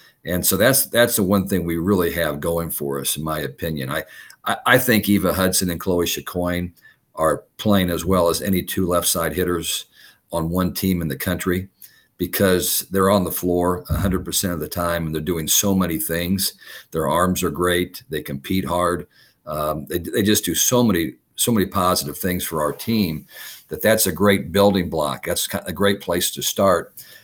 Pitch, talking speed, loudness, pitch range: 90 Hz, 195 wpm, -20 LUFS, 85-95 Hz